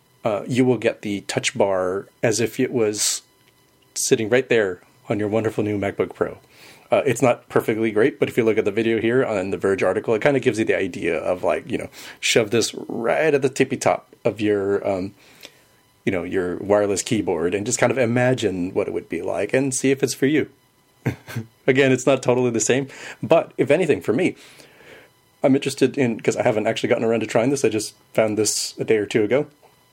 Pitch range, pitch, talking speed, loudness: 110-135 Hz, 115 Hz, 225 wpm, -21 LUFS